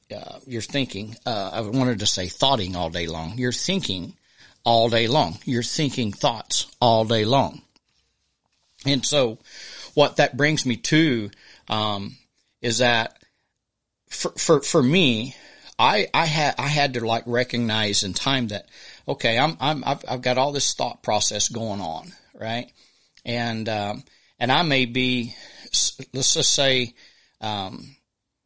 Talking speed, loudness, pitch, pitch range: 150 wpm, -22 LUFS, 120 Hz, 110-135 Hz